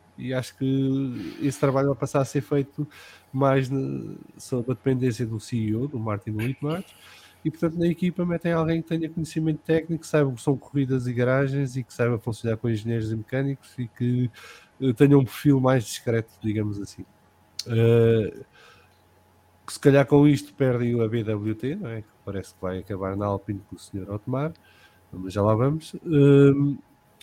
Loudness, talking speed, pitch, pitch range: -24 LUFS, 175 wpm, 130 Hz, 110-140 Hz